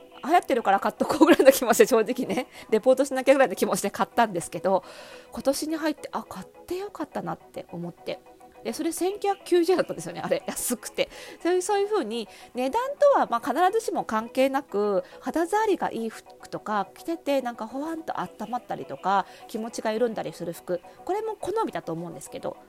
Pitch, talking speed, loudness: 255 Hz, 420 characters per minute, -26 LUFS